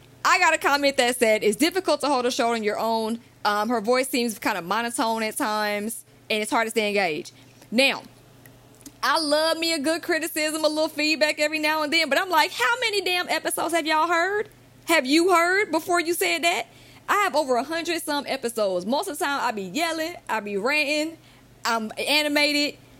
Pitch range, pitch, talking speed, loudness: 225-325 Hz, 295 Hz, 205 wpm, -23 LUFS